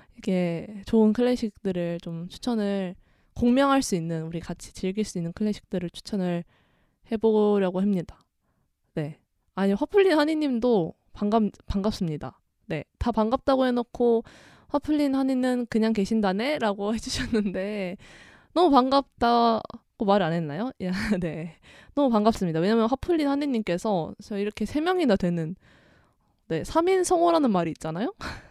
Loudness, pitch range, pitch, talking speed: -25 LUFS, 185-250 Hz, 215 Hz, 295 characters per minute